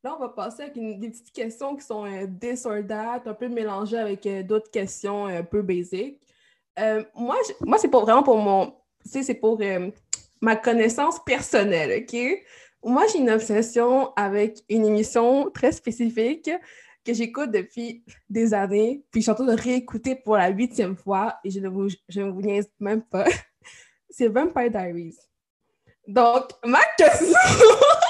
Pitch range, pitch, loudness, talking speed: 210-255 Hz, 230 Hz, -22 LUFS, 175 wpm